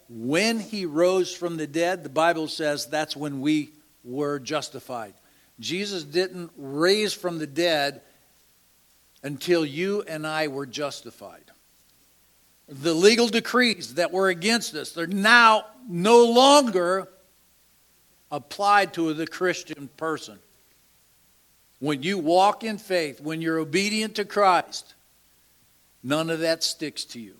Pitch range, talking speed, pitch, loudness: 145-190 Hz, 125 wpm, 165 Hz, -23 LUFS